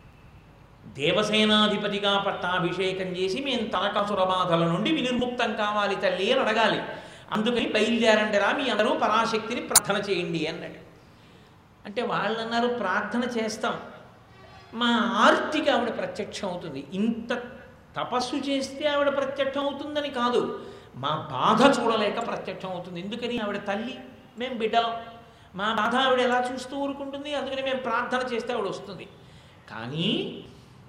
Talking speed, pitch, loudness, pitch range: 115 wpm, 225 Hz, -25 LUFS, 200-250 Hz